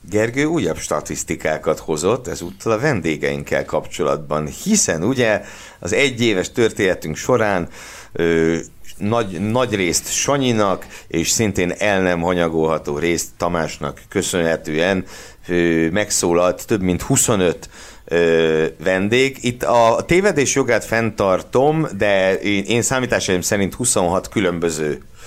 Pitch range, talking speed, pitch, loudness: 85-115 Hz, 110 wpm, 95 Hz, -18 LUFS